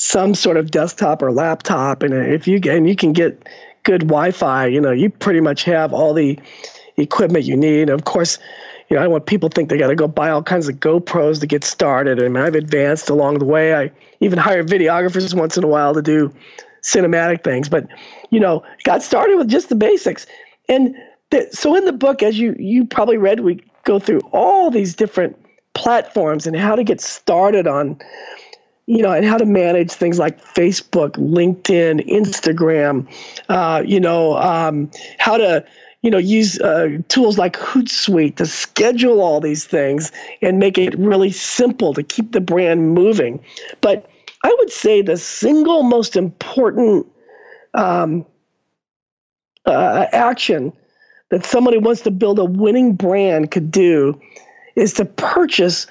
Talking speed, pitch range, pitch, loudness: 175 wpm, 155-225 Hz, 180 Hz, -15 LUFS